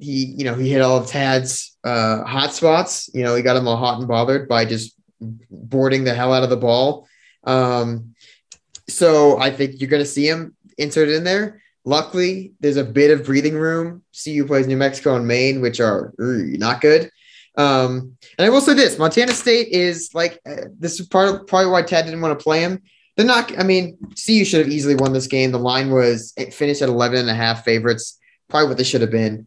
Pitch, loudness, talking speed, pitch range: 140 Hz, -17 LUFS, 225 wpm, 125-165 Hz